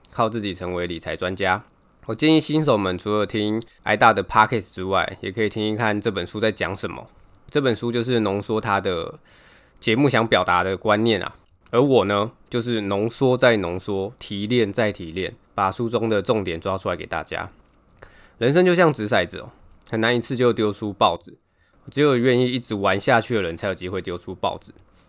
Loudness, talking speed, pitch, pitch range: -21 LUFS, 300 characters per minute, 105 Hz, 95-120 Hz